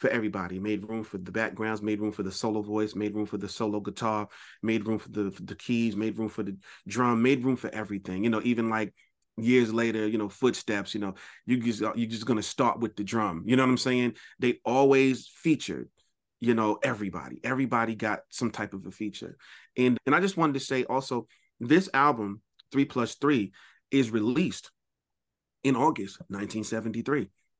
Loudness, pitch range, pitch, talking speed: -28 LUFS, 105-125 Hz, 110 Hz, 200 wpm